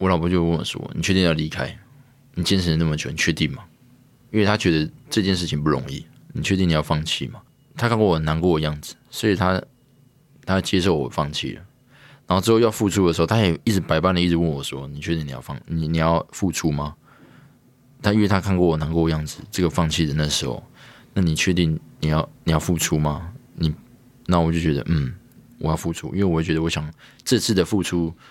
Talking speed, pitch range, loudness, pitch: 320 characters per minute, 80-110 Hz, -22 LUFS, 85 Hz